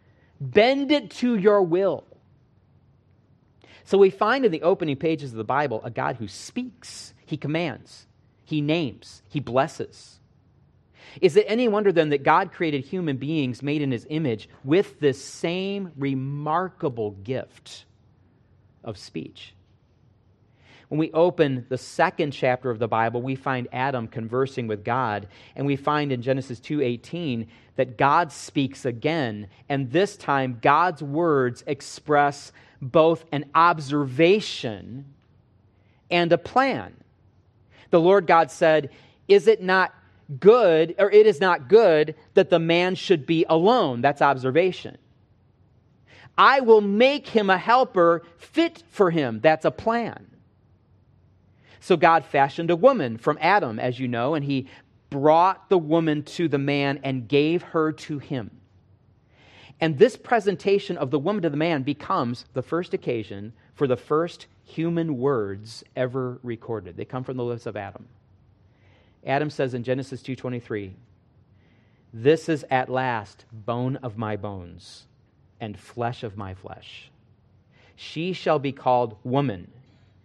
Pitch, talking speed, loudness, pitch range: 135 Hz, 140 wpm, -23 LUFS, 115-165 Hz